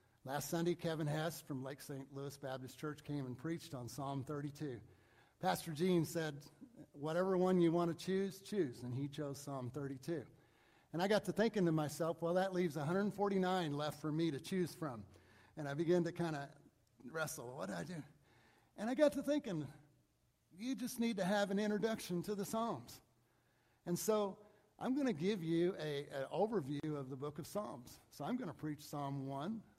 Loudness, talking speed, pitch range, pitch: -40 LUFS, 190 wpm, 140-190 Hz, 160 Hz